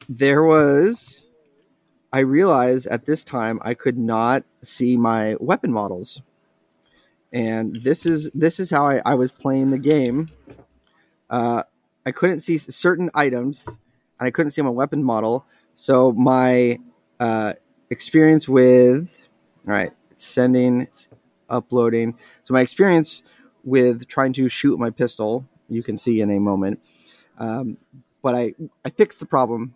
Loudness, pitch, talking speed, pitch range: -19 LUFS, 125 Hz, 145 wpm, 115-140 Hz